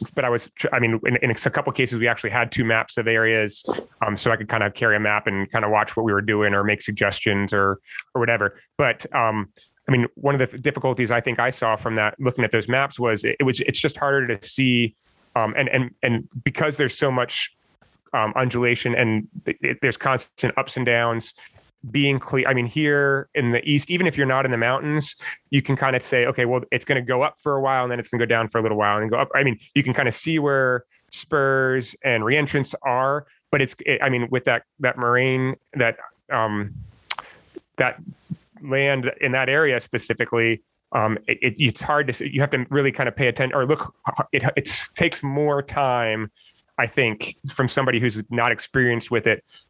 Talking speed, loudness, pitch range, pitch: 225 wpm, -21 LUFS, 115-140 Hz, 125 Hz